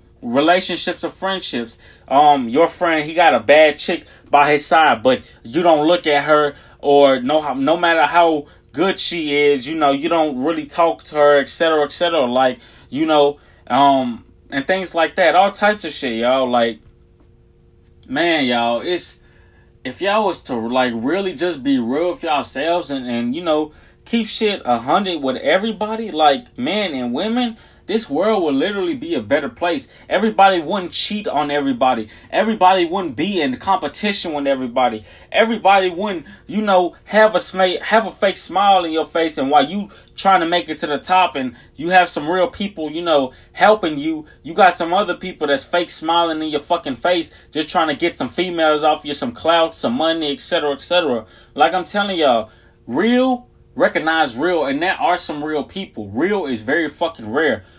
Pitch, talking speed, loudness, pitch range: 165 Hz, 190 wpm, -17 LUFS, 145-190 Hz